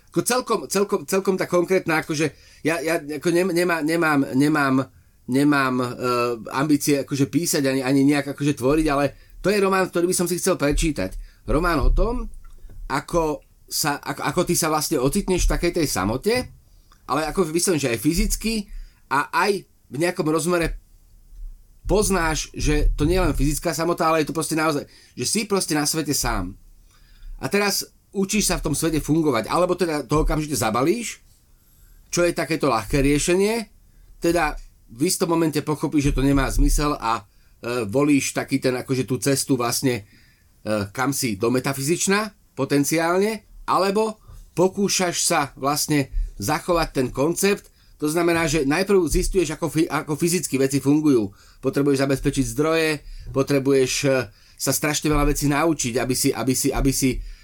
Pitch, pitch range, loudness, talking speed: 150 Hz, 130-170 Hz, -22 LUFS, 160 wpm